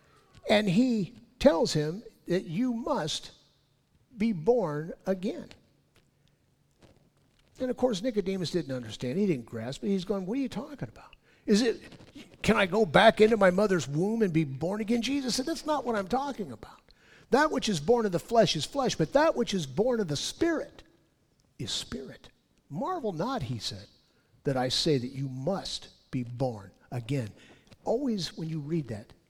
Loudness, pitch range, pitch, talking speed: -29 LUFS, 150-235 Hz, 200 Hz, 175 wpm